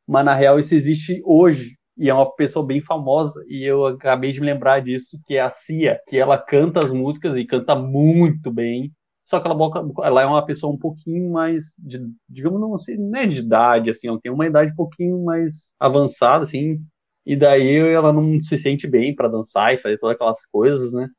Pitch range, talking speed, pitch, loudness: 130-160 Hz, 205 wpm, 145 Hz, -18 LUFS